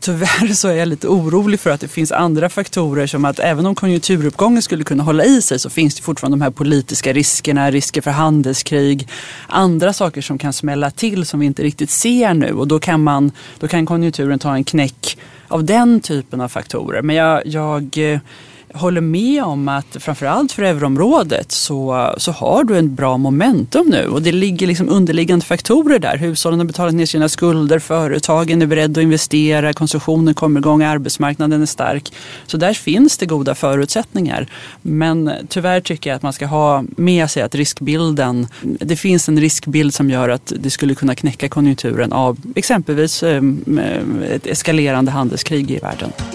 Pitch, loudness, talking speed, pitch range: 155 Hz, -15 LUFS, 180 wpm, 140-170 Hz